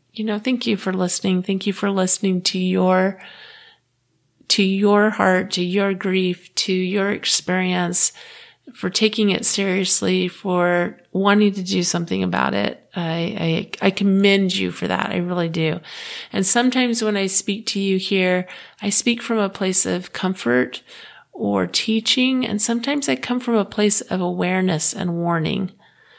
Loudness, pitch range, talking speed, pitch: -19 LUFS, 180-210 Hz, 160 wpm, 195 Hz